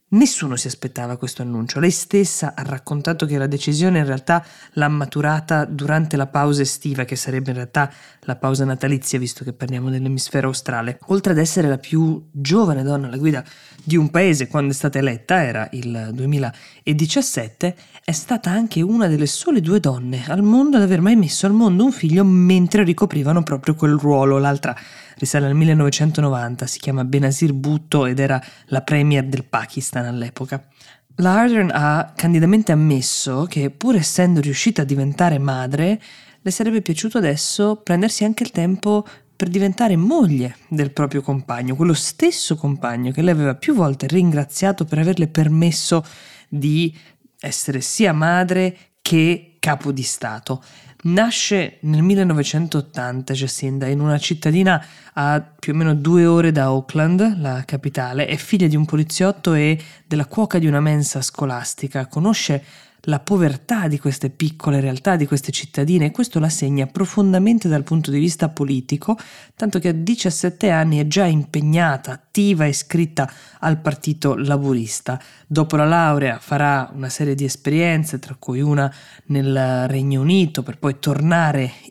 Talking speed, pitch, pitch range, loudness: 160 wpm, 150 Hz, 135-170 Hz, -18 LUFS